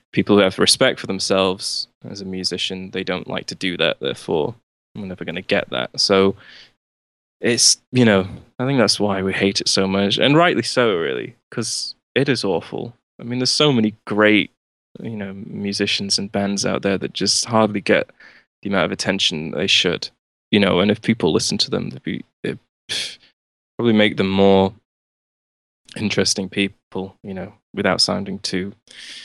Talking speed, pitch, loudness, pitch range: 180 wpm, 100 Hz, -19 LUFS, 95-105 Hz